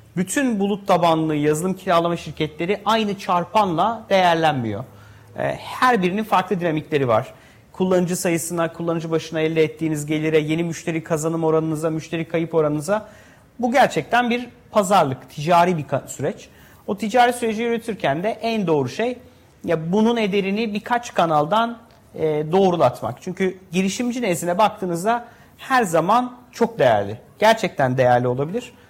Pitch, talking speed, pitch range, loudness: 175 Hz, 125 wpm, 160-215 Hz, -20 LUFS